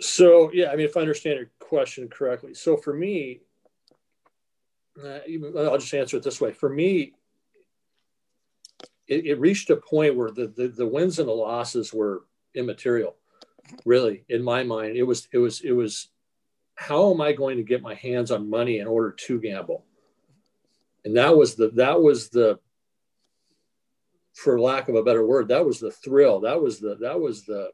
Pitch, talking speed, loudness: 150 Hz, 185 wpm, -23 LUFS